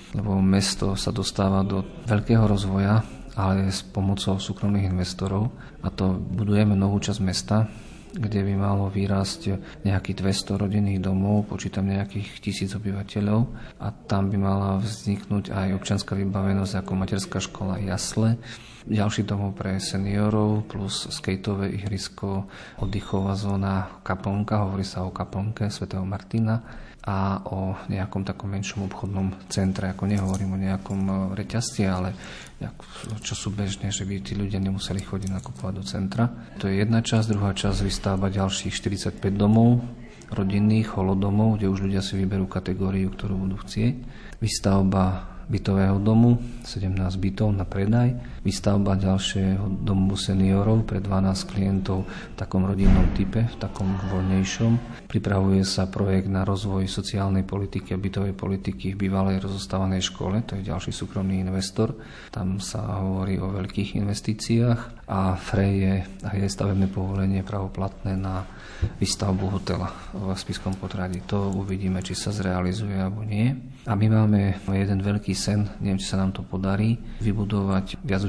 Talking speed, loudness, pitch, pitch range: 145 wpm, -25 LUFS, 95 Hz, 95-105 Hz